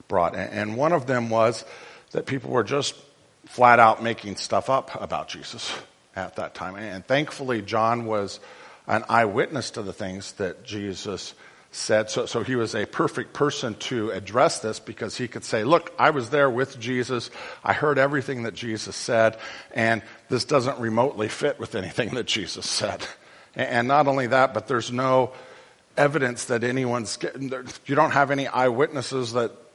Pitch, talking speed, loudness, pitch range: 120 Hz, 175 wpm, -24 LUFS, 110-135 Hz